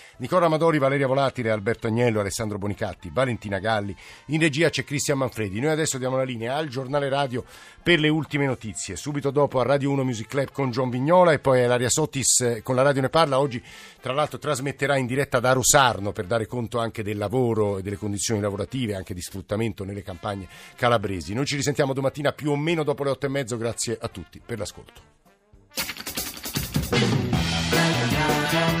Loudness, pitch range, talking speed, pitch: -24 LUFS, 110-140 Hz, 180 wpm, 130 Hz